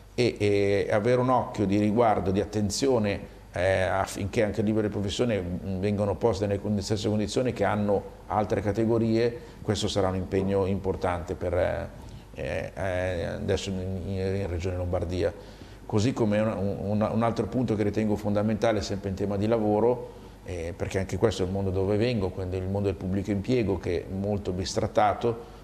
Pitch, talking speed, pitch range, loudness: 100 Hz, 165 wpm, 95-110 Hz, -27 LUFS